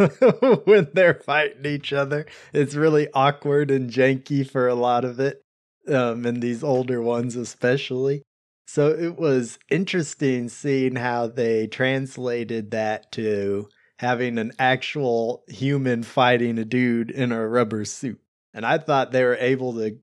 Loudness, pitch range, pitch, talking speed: -22 LUFS, 120-140 Hz, 125 Hz, 145 wpm